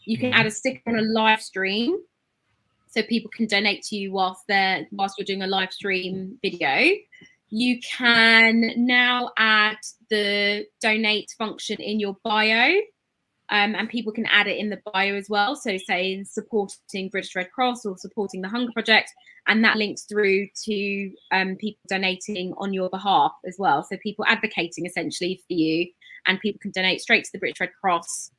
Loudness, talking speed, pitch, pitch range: -22 LUFS, 180 wpm, 210 Hz, 190-225 Hz